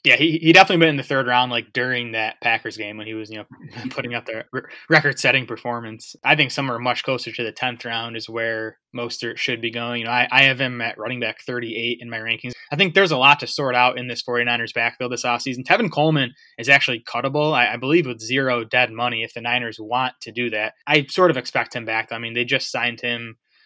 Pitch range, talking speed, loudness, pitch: 115-135 Hz, 250 wpm, -20 LUFS, 120 Hz